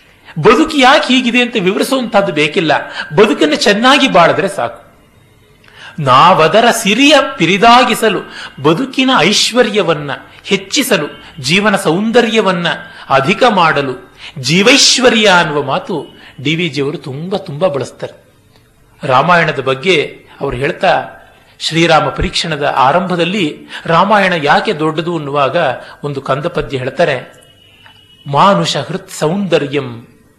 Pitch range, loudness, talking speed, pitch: 150-225 Hz, -11 LUFS, 90 wpm, 185 Hz